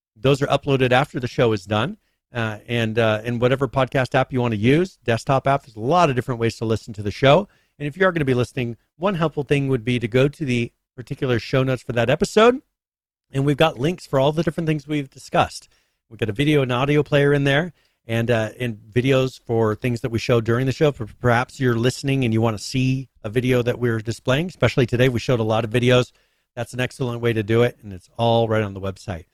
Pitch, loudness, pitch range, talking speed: 125 Hz, -21 LUFS, 115-140 Hz, 250 wpm